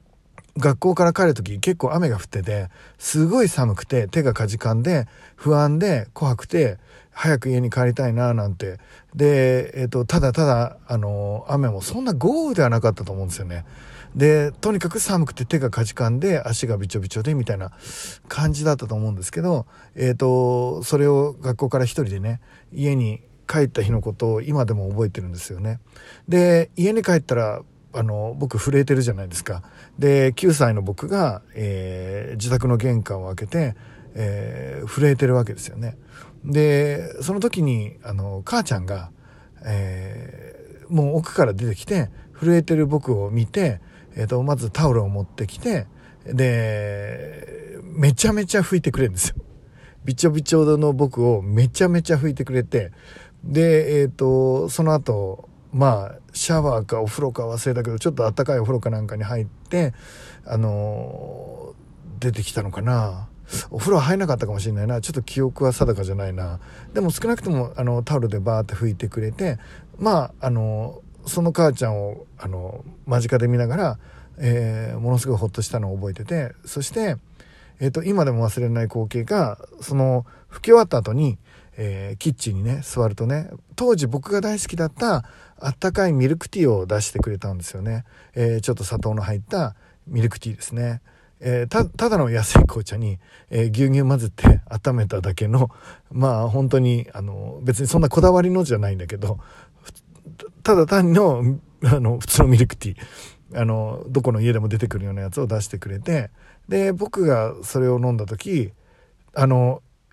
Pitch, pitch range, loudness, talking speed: 125 Hz, 110-150 Hz, -21 LUFS, 340 characters per minute